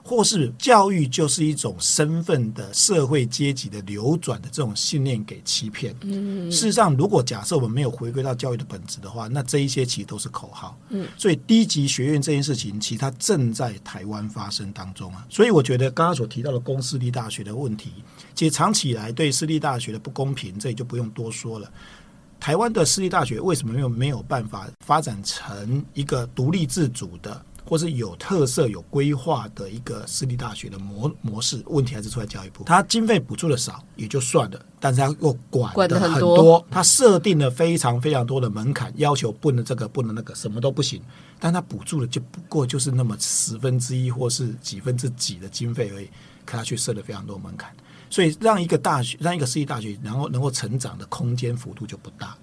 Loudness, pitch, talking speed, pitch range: -22 LUFS, 135 Hz, 325 characters per minute, 115-155 Hz